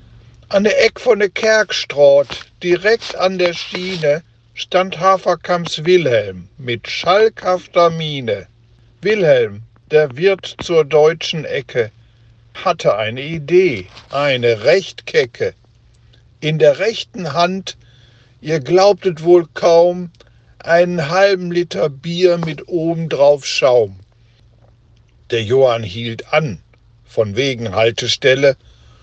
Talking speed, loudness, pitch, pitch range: 100 wpm, -15 LUFS, 155 Hz, 115-180 Hz